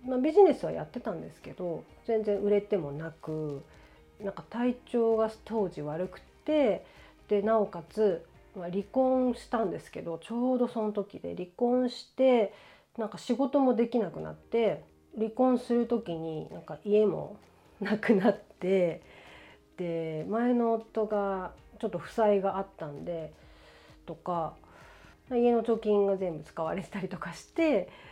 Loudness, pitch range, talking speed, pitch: -30 LUFS, 175-235 Hz, 275 characters per minute, 210 Hz